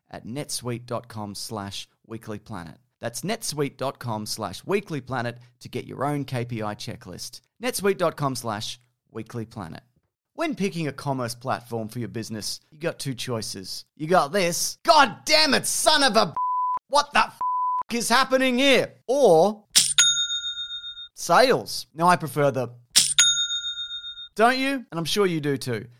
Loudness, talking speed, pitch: -23 LUFS, 135 wpm, 150 Hz